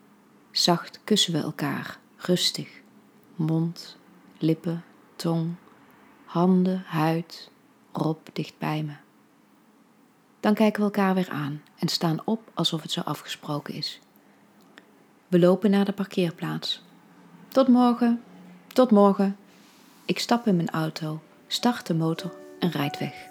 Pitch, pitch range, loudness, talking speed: 175 Hz, 160-205 Hz, -25 LUFS, 125 wpm